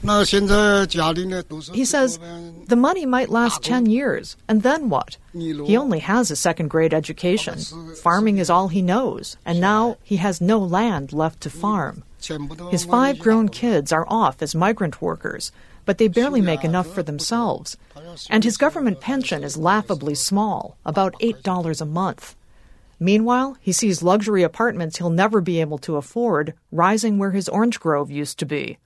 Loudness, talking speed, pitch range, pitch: -20 LUFS, 160 wpm, 165-225 Hz, 190 Hz